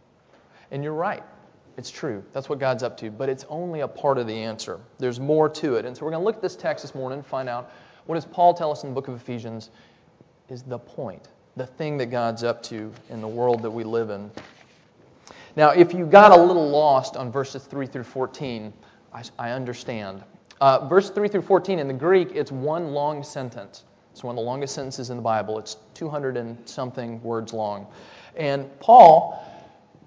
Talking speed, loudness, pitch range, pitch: 210 wpm, -21 LUFS, 115-150 Hz, 130 Hz